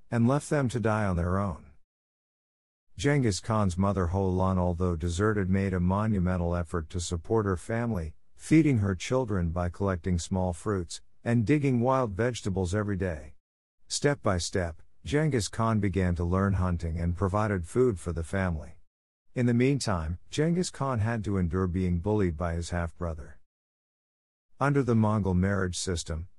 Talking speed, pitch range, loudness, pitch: 155 wpm, 85-110 Hz, -28 LUFS, 95 Hz